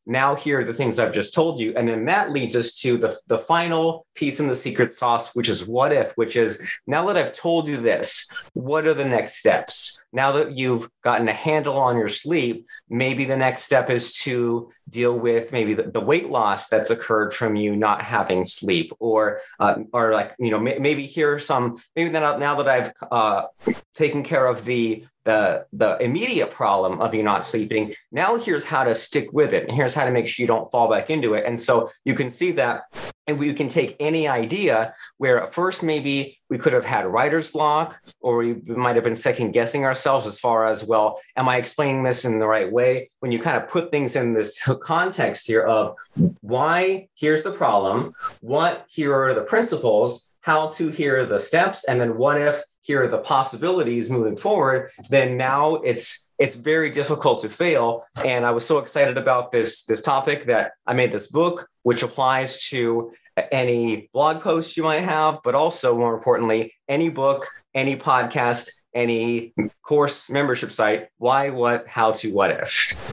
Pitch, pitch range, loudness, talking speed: 130 Hz, 115-150 Hz, -21 LUFS, 195 wpm